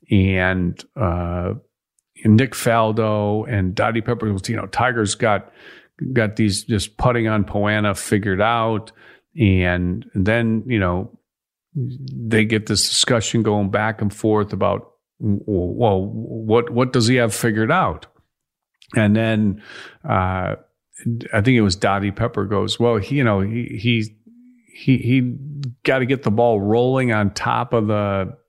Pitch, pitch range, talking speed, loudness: 110 Hz, 100-120 Hz, 145 wpm, -19 LUFS